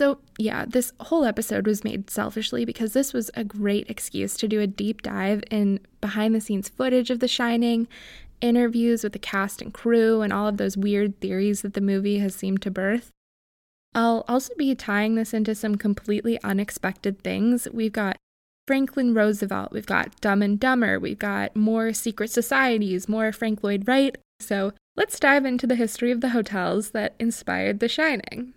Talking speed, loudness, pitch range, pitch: 185 wpm, -24 LUFS, 205-240 Hz, 220 Hz